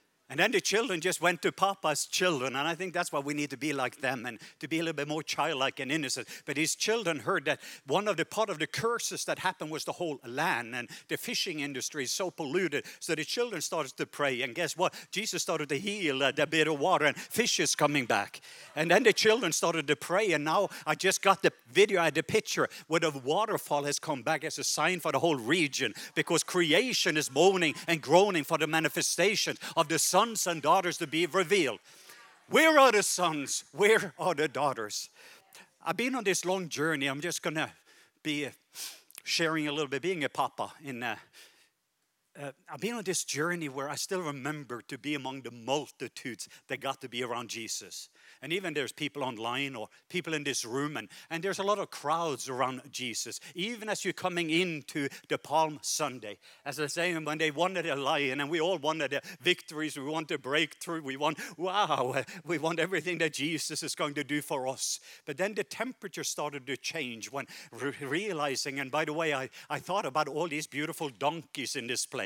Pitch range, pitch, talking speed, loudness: 140-175 Hz, 155 Hz, 215 wpm, -30 LUFS